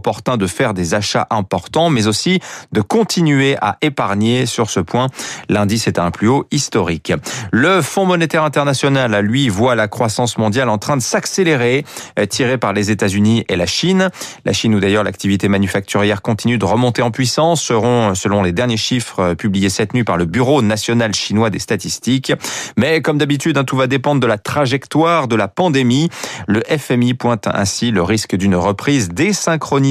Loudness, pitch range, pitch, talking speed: -15 LUFS, 105-140 Hz, 120 Hz, 180 wpm